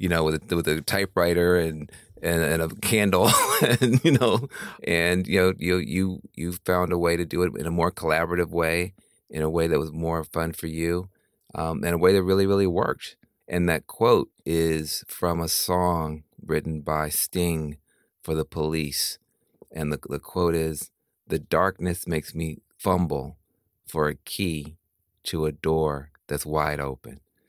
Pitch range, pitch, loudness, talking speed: 80-90 Hz, 85 Hz, -25 LUFS, 175 wpm